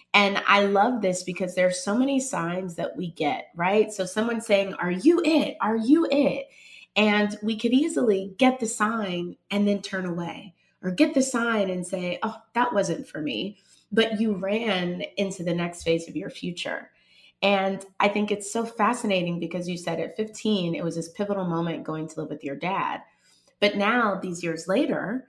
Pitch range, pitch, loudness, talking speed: 180-225 Hz, 200 Hz, -25 LUFS, 195 wpm